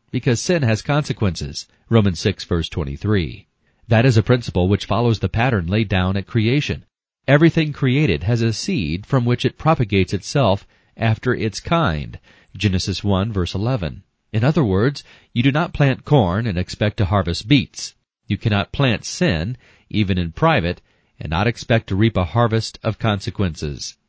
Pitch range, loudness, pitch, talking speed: 95-125 Hz, -19 LUFS, 110 Hz, 165 wpm